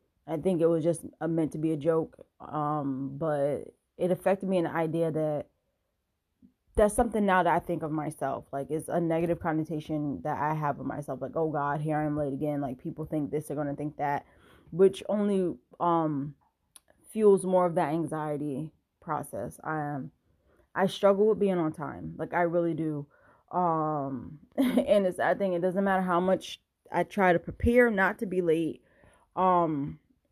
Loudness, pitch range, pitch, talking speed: -29 LUFS, 150-180 Hz, 160 Hz, 185 wpm